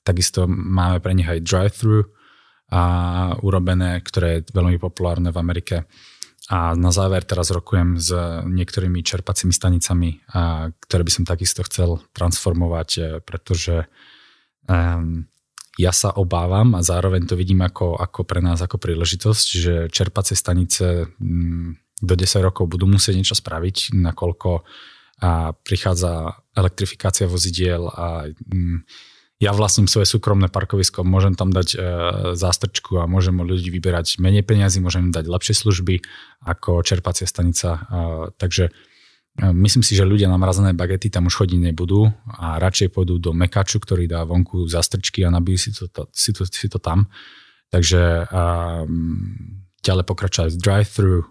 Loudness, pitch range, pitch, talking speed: -19 LUFS, 85-95 Hz, 90 Hz, 145 wpm